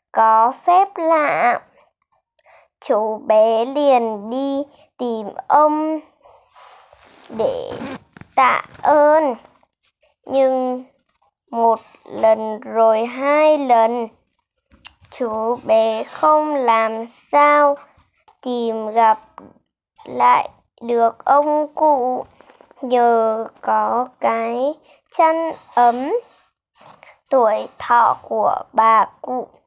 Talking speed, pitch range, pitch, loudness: 80 wpm, 225-295 Hz, 250 Hz, -17 LUFS